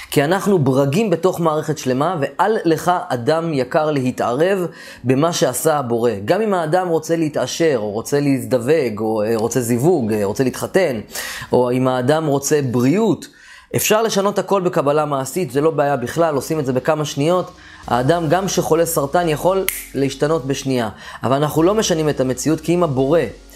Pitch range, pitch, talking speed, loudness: 130-170 Hz, 155 Hz, 160 wpm, -18 LUFS